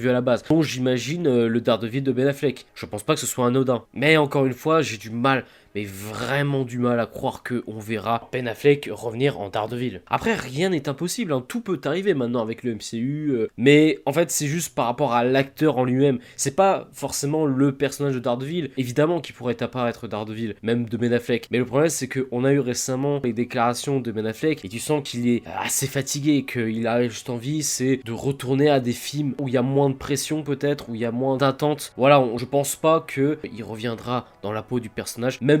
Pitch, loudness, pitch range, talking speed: 130 Hz, -23 LUFS, 120-145 Hz, 235 wpm